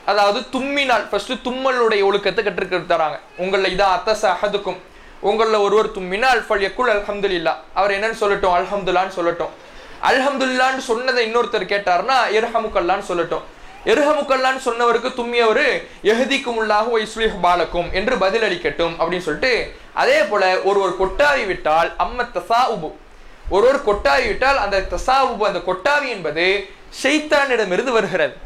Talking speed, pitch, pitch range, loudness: 110 wpm, 210 Hz, 185-250 Hz, -18 LUFS